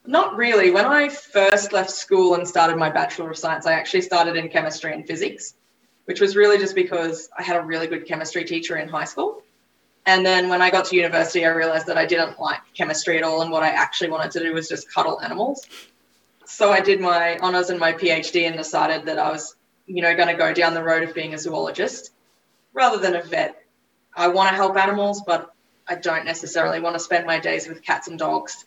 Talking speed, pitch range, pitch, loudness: 230 wpm, 165-190 Hz, 170 Hz, -20 LUFS